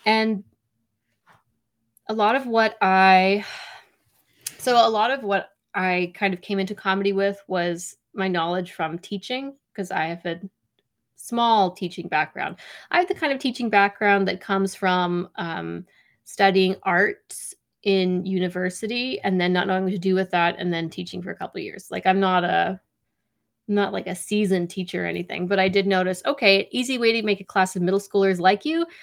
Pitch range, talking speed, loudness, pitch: 180-205 Hz, 185 wpm, -22 LUFS, 190 Hz